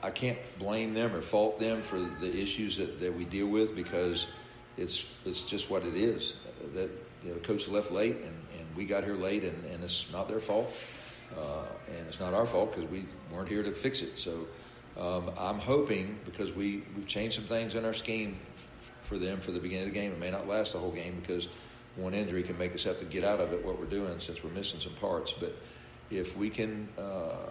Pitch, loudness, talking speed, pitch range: 100 Hz, -35 LUFS, 235 wpm, 90-105 Hz